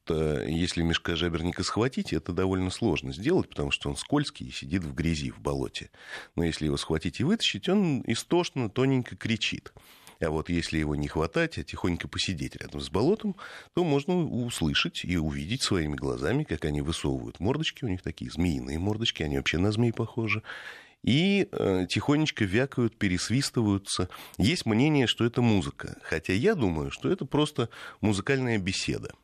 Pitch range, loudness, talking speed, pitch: 80-125 Hz, -28 LUFS, 160 wpm, 95 Hz